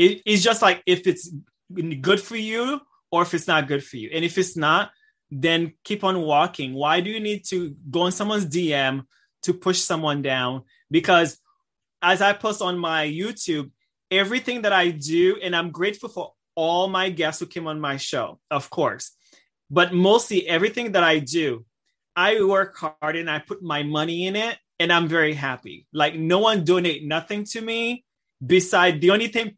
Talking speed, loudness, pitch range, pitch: 190 wpm, -22 LUFS, 155-205 Hz, 180 Hz